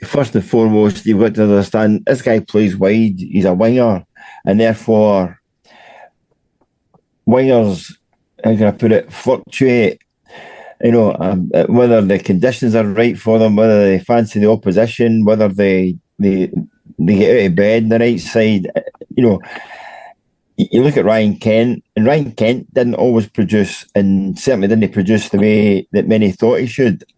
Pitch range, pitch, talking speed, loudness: 100-115 Hz, 110 Hz, 165 wpm, -13 LUFS